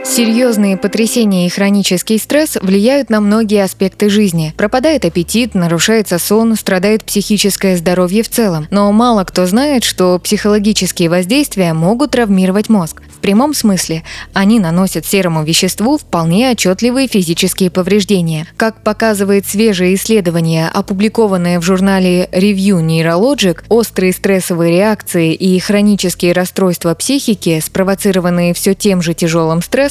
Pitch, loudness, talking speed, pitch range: 195 Hz, -12 LUFS, 125 wpm, 180-220 Hz